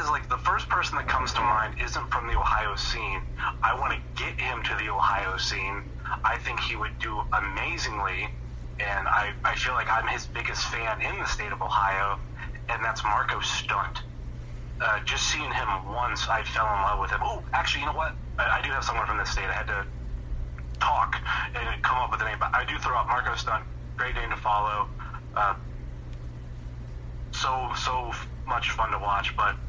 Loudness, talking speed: -27 LUFS, 200 wpm